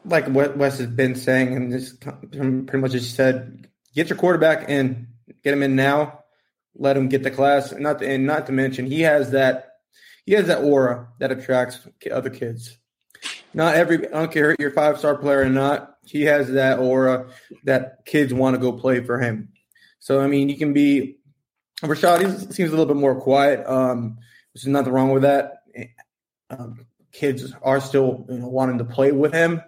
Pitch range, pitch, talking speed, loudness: 130-145 Hz, 135 Hz, 200 wpm, -20 LUFS